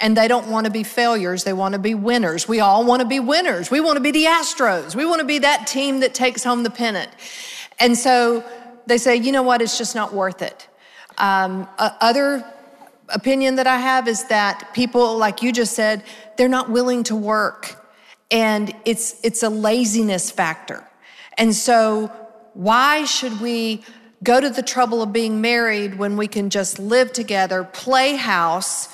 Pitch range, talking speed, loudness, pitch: 215-250 Hz, 190 wpm, -18 LUFS, 230 Hz